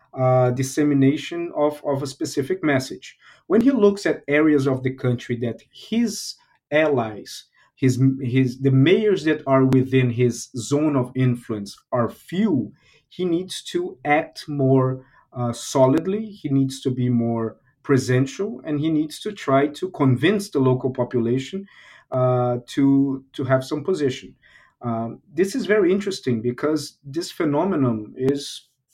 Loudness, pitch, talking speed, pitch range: -21 LUFS, 135 Hz, 145 wpm, 130-155 Hz